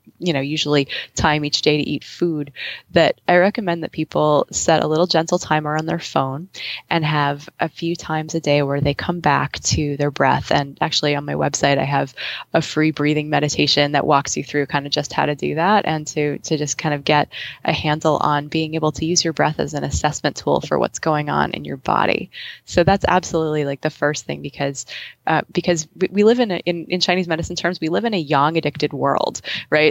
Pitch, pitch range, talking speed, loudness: 155 Hz, 145-170 Hz, 225 wpm, -19 LUFS